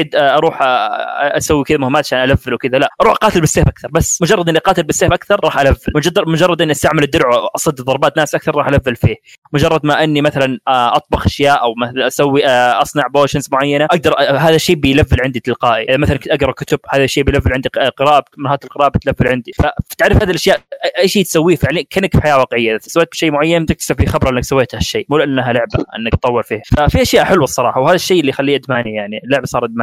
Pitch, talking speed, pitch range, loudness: 145 Hz, 205 wpm, 130-160 Hz, -13 LUFS